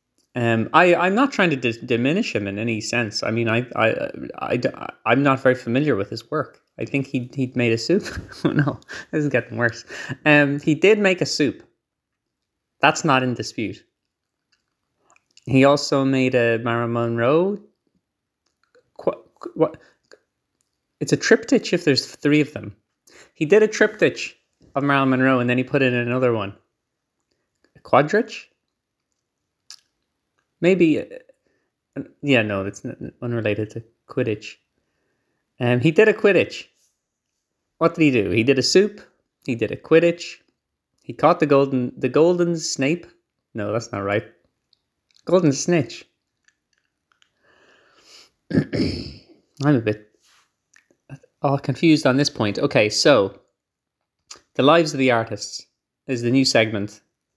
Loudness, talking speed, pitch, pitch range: -20 LUFS, 145 wpm, 135 Hz, 115-160 Hz